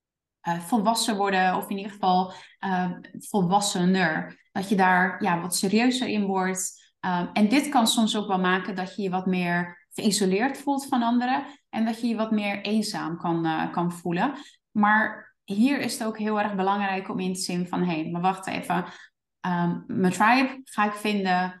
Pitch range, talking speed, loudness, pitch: 185-220 Hz, 190 wpm, -25 LUFS, 200 Hz